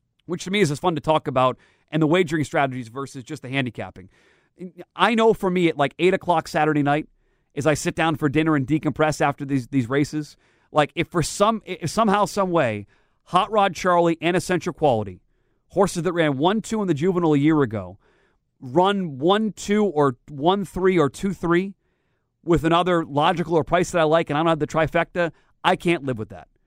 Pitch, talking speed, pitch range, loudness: 160 Hz, 205 wpm, 145-180 Hz, -21 LUFS